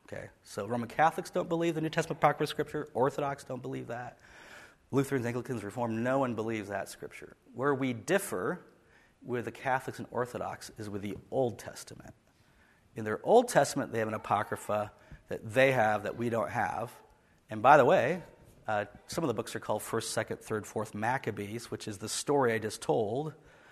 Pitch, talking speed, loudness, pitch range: 115 Hz, 185 wpm, -31 LUFS, 110-135 Hz